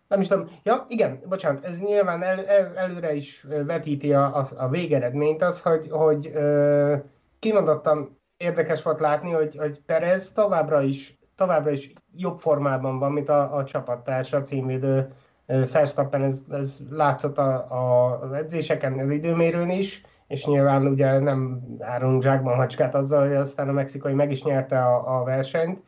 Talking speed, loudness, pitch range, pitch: 160 wpm, -23 LUFS, 135-165 Hz, 145 Hz